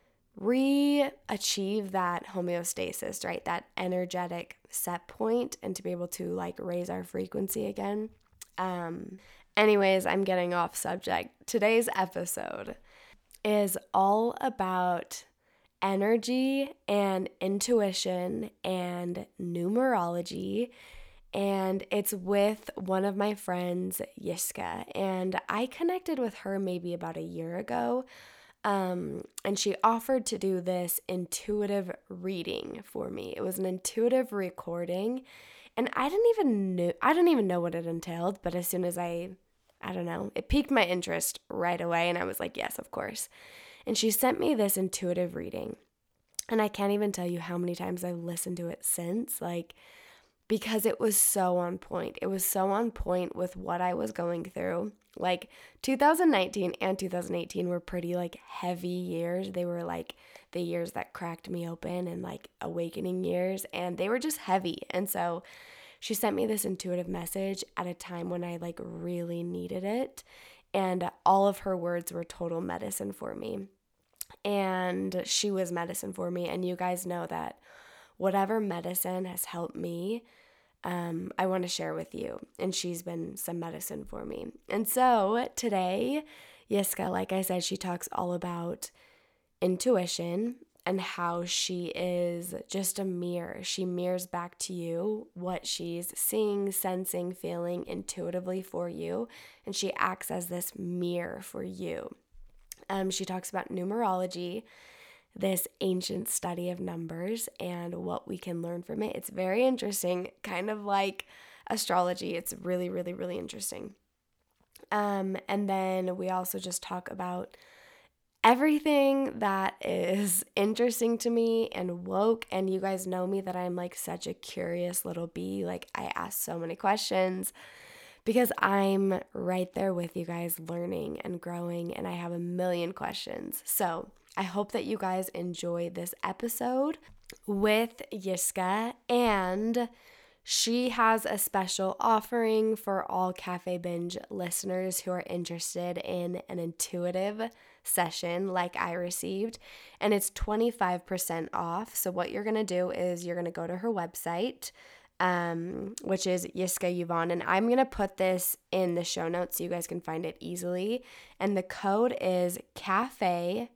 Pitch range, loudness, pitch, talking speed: 175-215 Hz, -31 LUFS, 185 Hz, 155 wpm